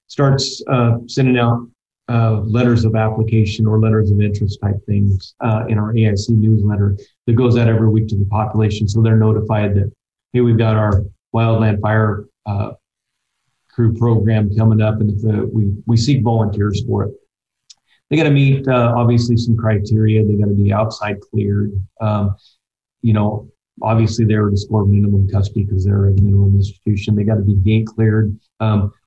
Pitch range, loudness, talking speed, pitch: 105-115 Hz, -16 LUFS, 180 wpm, 110 Hz